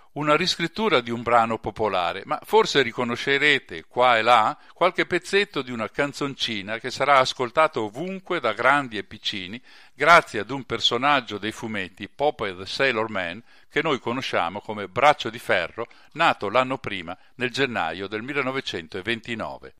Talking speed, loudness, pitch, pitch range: 150 wpm, -23 LUFS, 130 Hz, 110-145 Hz